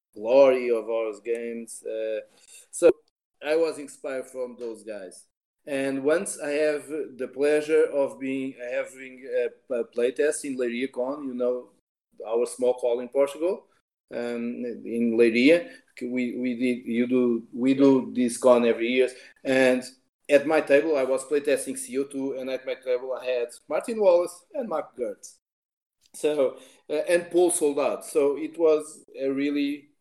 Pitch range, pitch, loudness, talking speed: 125-165 Hz, 135 Hz, -25 LUFS, 155 wpm